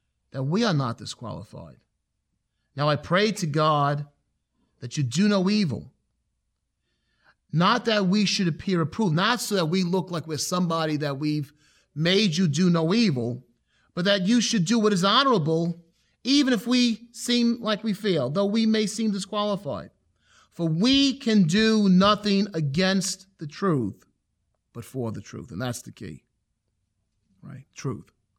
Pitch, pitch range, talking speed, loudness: 185 Hz, 150-210 Hz, 155 wpm, -24 LUFS